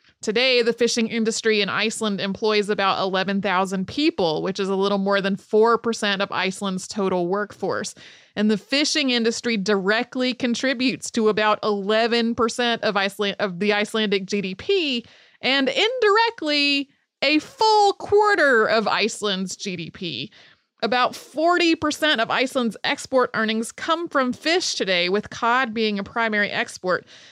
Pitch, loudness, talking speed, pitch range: 225 Hz, -21 LUFS, 130 wpm, 200-260 Hz